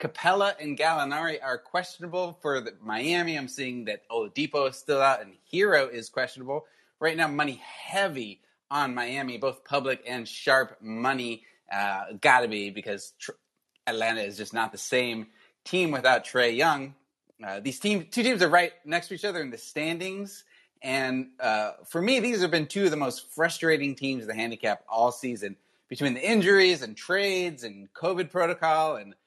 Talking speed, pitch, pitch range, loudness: 175 wpm, 140 Hz, 120-175 Hz, -27 LUFS